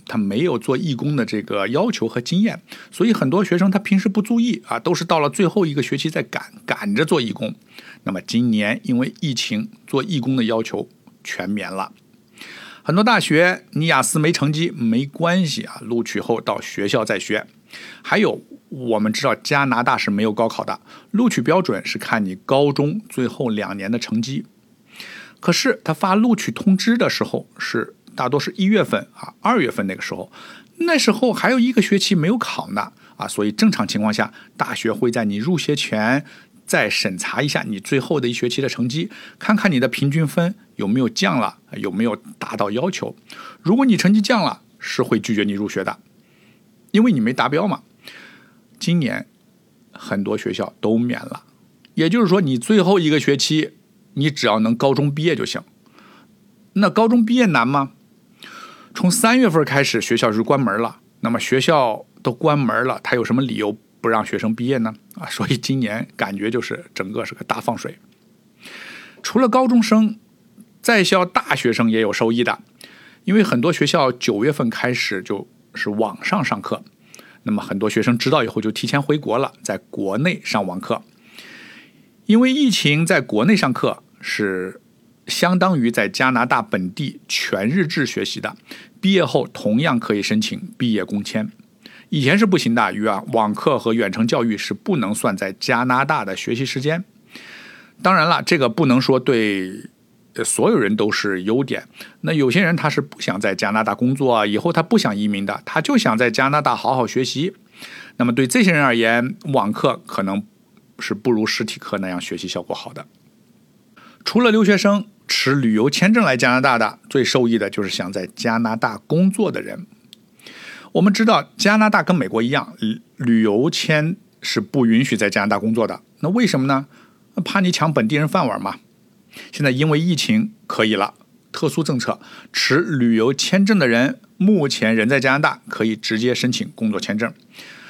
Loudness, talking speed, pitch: -19 LUFS, 265 characters per minute, 155 Hz